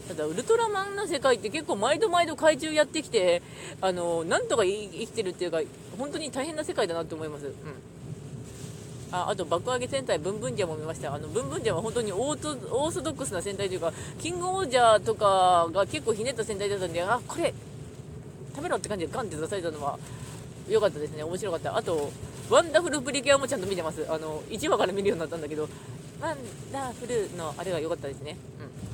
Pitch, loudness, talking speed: 190 Hz, -28 LUFS, 460 characters per minute